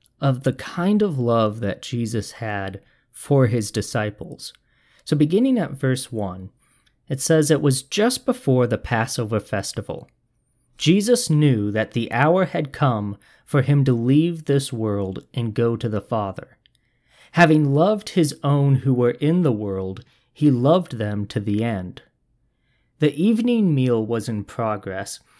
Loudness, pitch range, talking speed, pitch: -21 LUFS, 110-150 Hz, 150 wpm, 125 Hz